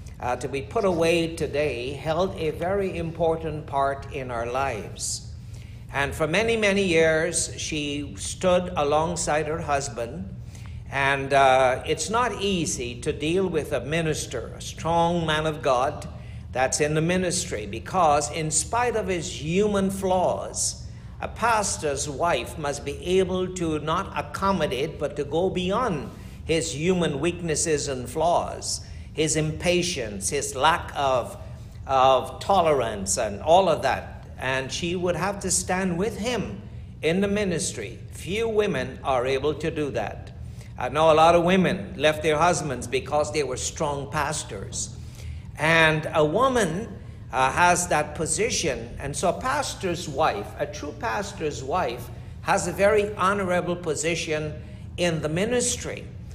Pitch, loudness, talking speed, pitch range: 155 Hz, -24 LUFS, 145 wpm, 130-175 Hz